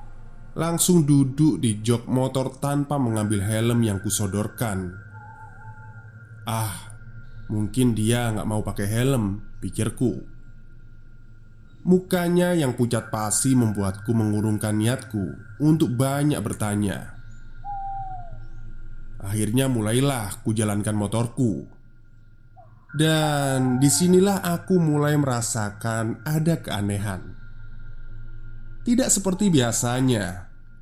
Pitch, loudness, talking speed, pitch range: 115 Hz, -23 LUFS, 80 wpm, 110-130 Hz